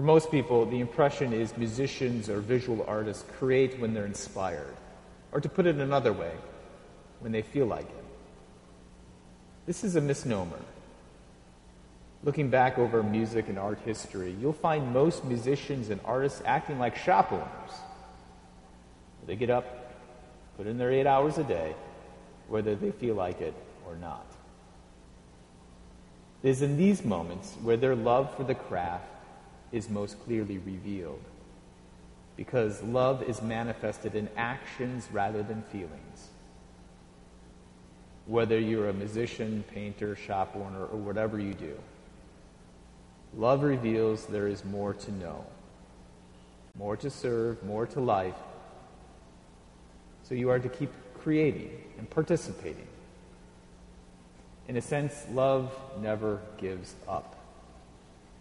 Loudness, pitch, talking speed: -31 LUFS, 105 Hz, 130 wpm